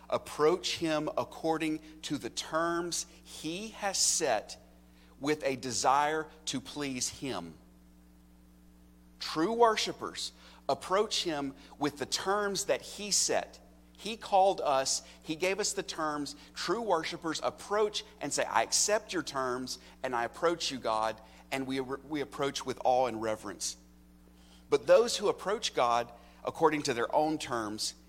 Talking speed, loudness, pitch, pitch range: 140 wpm, -32 LUFS, 140 Hz, 105-170 Hz